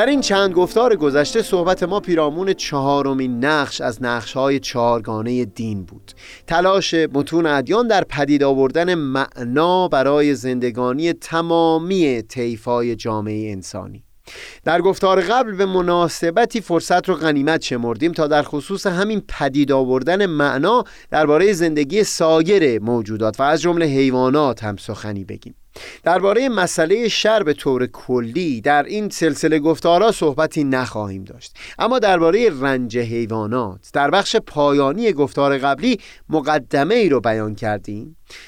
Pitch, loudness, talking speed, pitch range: 145 Hz, -18 LUFS, 130 wpm, 125-175 Hz